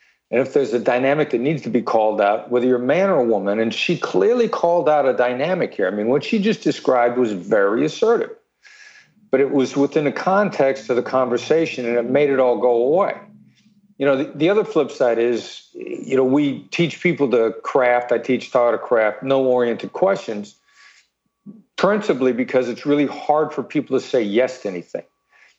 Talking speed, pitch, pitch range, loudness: 200 wpm, 140 Hz, 125-195 Hz, -19 LUFS